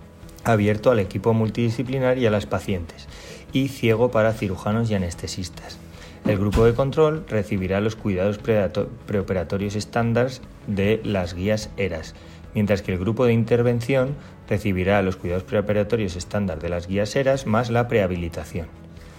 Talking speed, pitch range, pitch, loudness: 140 wpm, 90-115 Hz, 105 Hz, -23 LUFS